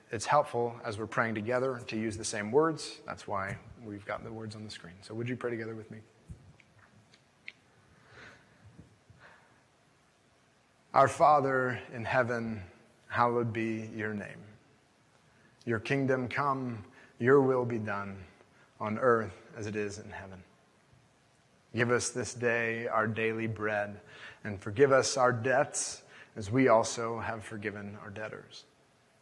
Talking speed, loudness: 140 wpm, -31 LUFS